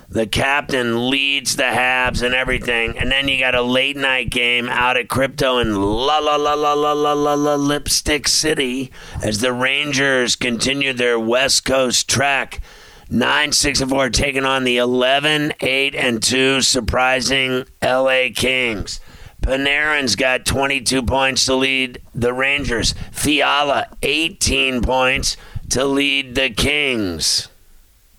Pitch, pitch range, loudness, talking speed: 130 Hz, 125-140 Hz, -16 LUFS, 145 wpm